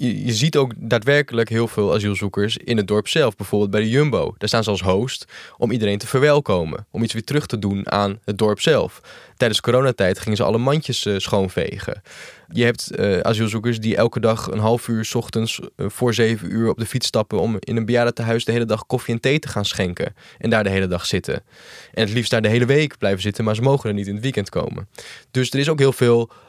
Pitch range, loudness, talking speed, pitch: 105-125 Hz, -20 LUFS, 230 wpm, 115 Hz